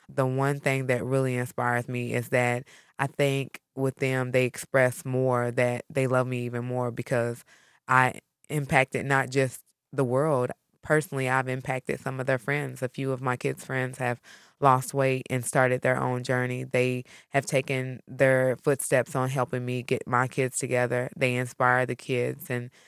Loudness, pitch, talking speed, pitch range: -27 LUFS, 130 Hz, 175 wpm, 125-135 Hz